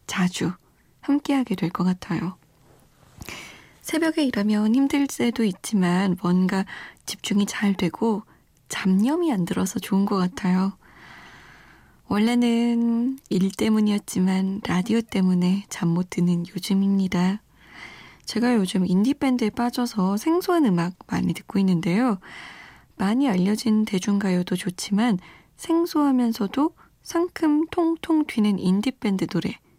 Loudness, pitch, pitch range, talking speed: -23 LUFS, 205 Hz, 185-245 Hz, 255 characters per minute